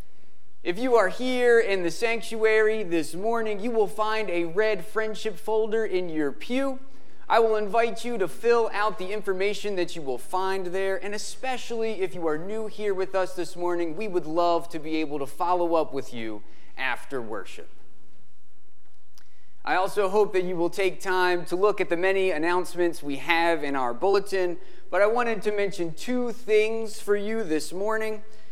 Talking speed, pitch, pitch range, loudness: 185 wpm, 190 Hz, 170-220 Hz, -26 LUFS